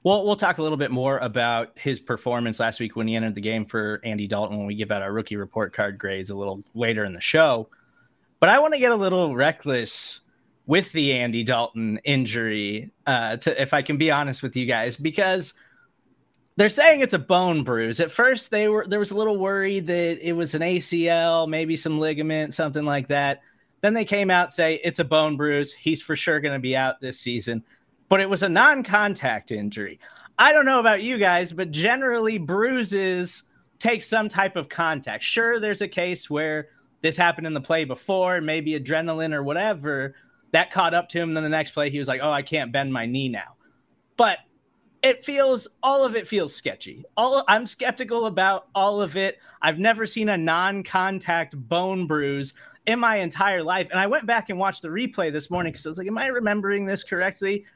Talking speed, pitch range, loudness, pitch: 210 wpm, 135-200 Hz, -22 LUFS, 165 Hz